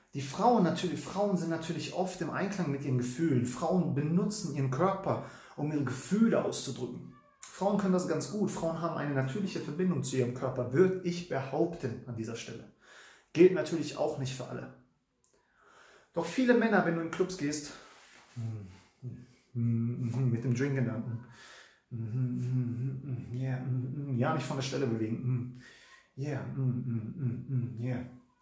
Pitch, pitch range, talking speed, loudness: 135 Hz, 125-165 Hz, 140 wpm, -32 LUFS